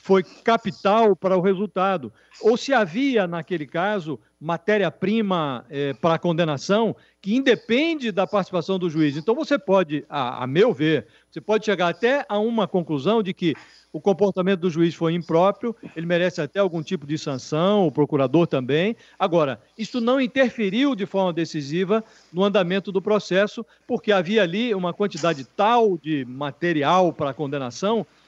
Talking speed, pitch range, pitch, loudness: 160 wpm, 165-215 Hz, 190 Hz, -22 LUFS